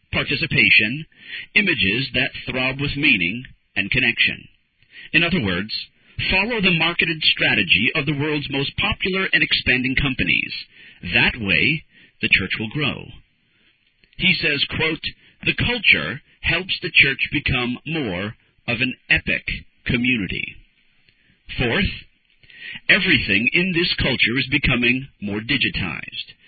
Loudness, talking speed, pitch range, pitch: -18 LUFS, 120 wpm, 120-155 Hz, 135 Hz